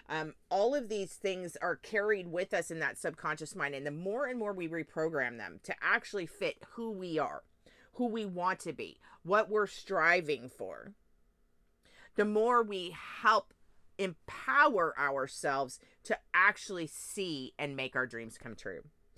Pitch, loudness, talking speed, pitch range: 175 Hz, -33 LUFS, 160 wpm, 145-205 Hz